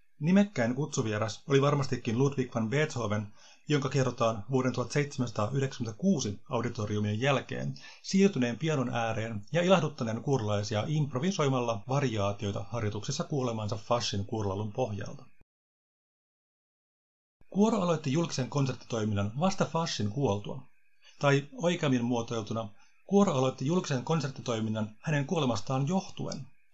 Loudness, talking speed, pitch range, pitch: -30 LUFS, 95 wpm, 110-145 Hz, 125 Hz